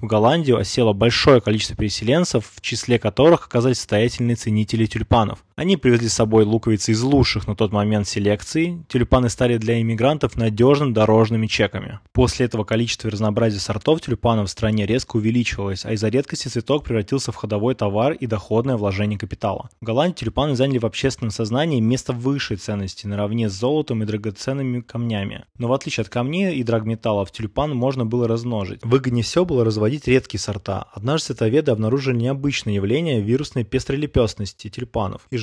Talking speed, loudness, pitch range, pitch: 160 wpm, -20 LUFS, 110-130 Hz, 115 Hz